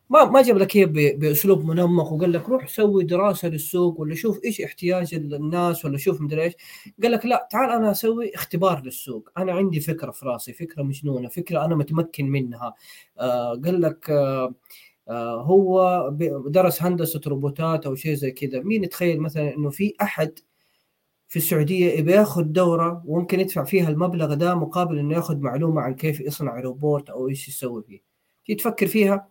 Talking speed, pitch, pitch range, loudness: 170 wpm, 165 Hz, 145-185 Hz, -22 LUFS